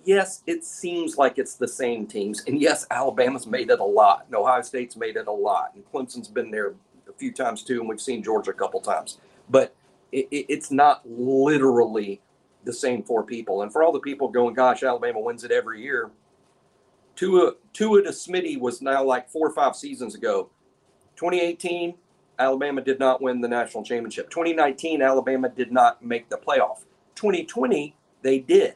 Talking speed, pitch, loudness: 185 wpm, 150 Hz, -23 LUFS